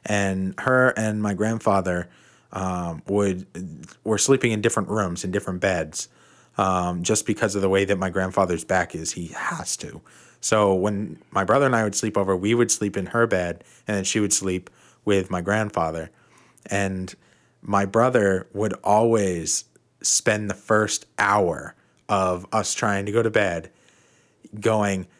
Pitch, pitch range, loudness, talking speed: 100 Hz, 95-110 Hz, -23 LUFS, 165 wpm